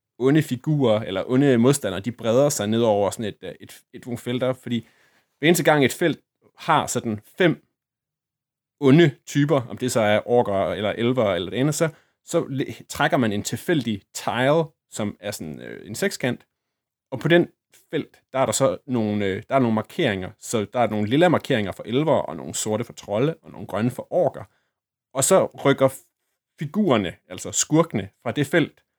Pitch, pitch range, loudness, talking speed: 130 Hz, 110-145 Hz, -22 LUFS, 185 wpm